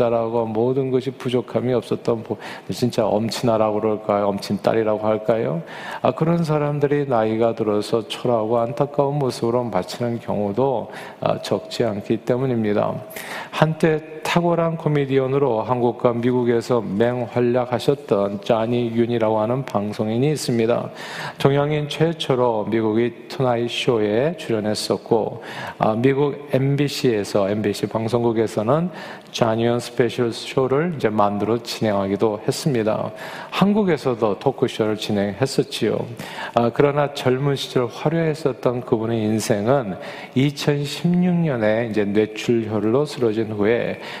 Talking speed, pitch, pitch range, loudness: 295 characters per minute, 120 Hz, 110-140 Hz, -21 LUFS